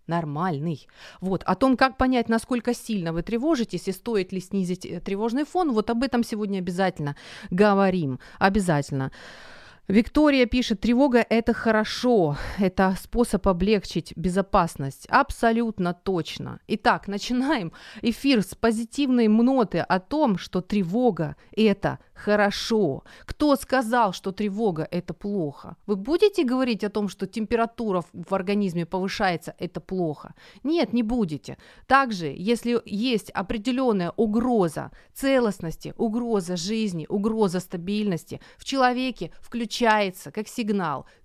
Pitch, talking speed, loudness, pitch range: 210 Hz, 120 wpm, -24 LUFS, 180-235 Hz